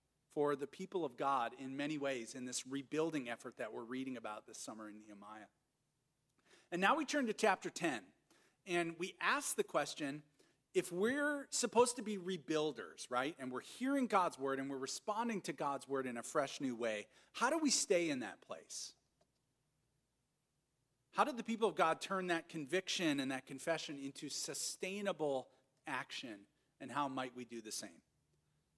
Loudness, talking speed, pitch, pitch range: -40 LUFS, 175 wpm, 150 Hz, 130-195 Hz